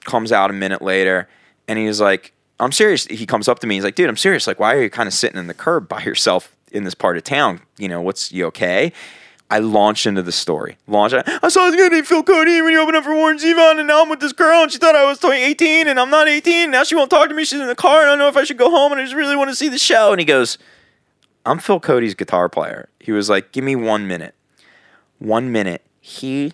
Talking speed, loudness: 280 wpm, -15 LUFS